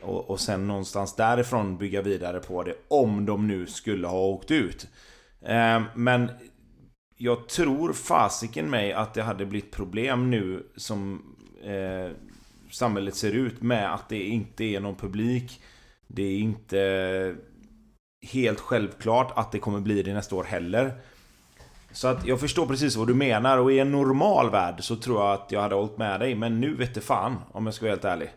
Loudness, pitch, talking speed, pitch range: -26 LUFS, 110 Hz, 175 wpm, 100-120 Hz